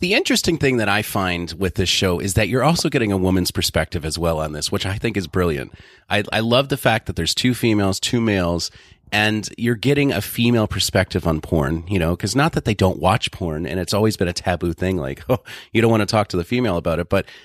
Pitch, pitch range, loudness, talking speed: 100 Hz, 90-115 Hz, -20 LUFS, 255 wpm